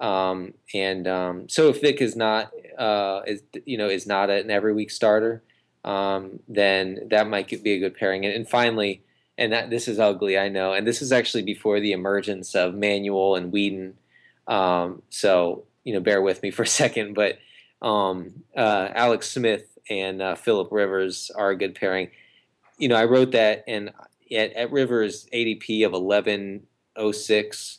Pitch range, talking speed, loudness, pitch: 95-110 Hz, 175 wpm, -23 LUFS, 105 Hz